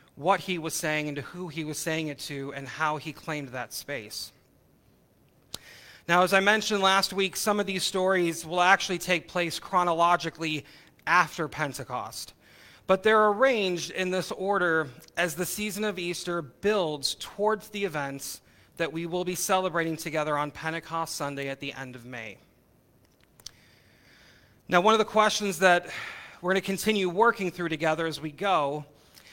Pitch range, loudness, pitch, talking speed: 150-190 Hz, -27 LUFS, 170 Hz, 165 wpm